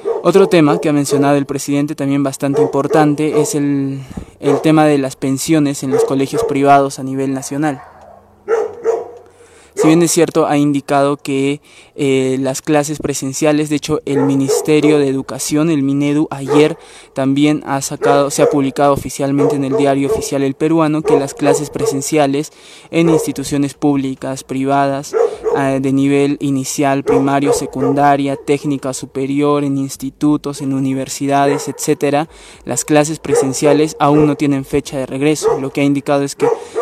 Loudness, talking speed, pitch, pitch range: -15 LUFS, 150 wpm, 145 Hz, 140-150 Hz